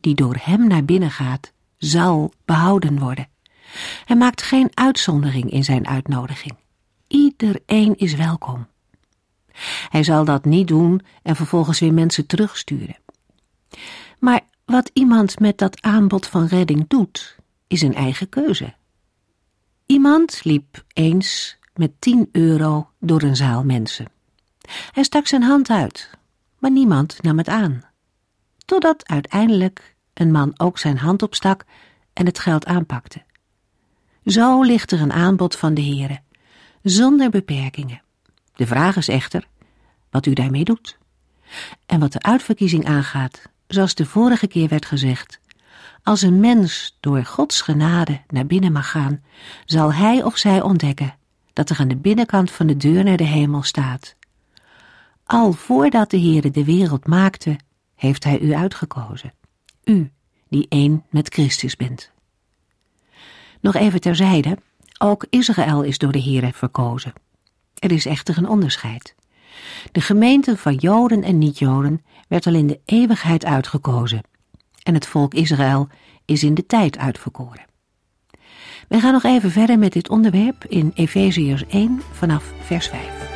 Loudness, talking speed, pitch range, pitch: -17 LUFS, 140 wpm, 140-200 Hz, 160 Hz